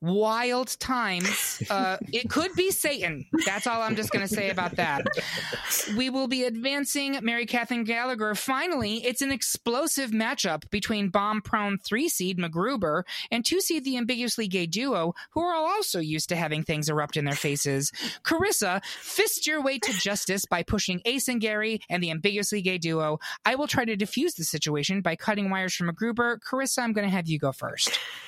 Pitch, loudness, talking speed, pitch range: 220 Hz, -27 LUFS, 185 wpm, 185-260 Hz